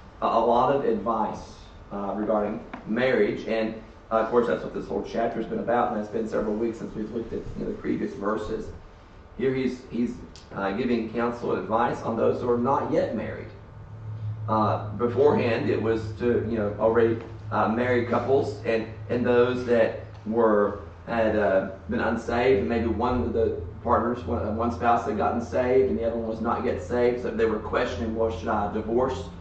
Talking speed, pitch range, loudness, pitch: 195 wpm, 105-120 Hz, -26 LUFS, 110 Hz